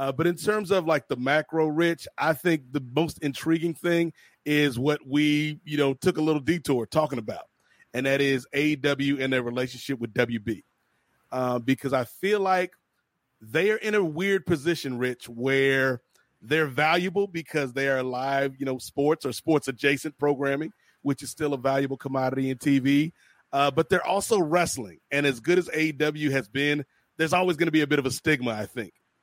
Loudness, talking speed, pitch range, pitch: -26 LUFS, 190 wpm, 135-160 Hz, 145 Hz